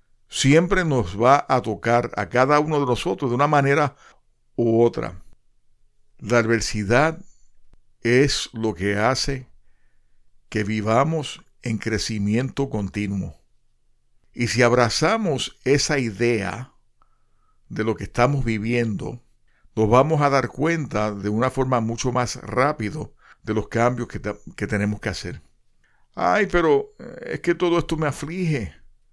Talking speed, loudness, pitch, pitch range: 130 wpm, -22 LUFS, 120 Hz, 110-140 Hz